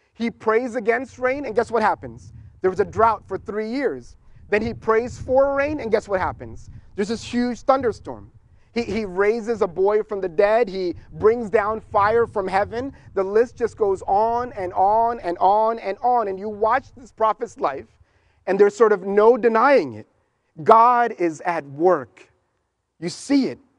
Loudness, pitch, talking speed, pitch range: -21 LUFS, 215 Hz, 185 wpm, 185-235 Hz